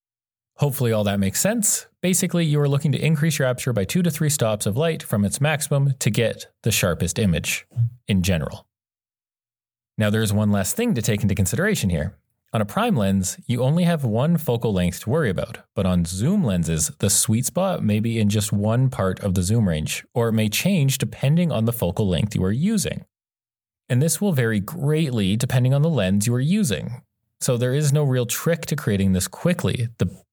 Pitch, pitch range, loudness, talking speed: 115 Hz, 105-150 Hz, -21 LUFS, 210 wpm